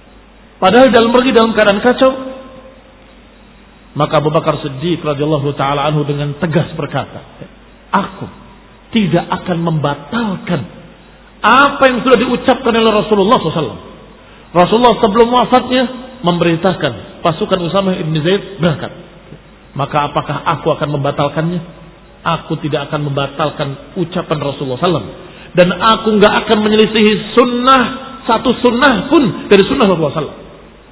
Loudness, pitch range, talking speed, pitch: -13 LUFS, 155-235 Hz, 115 wpm, 180 Hz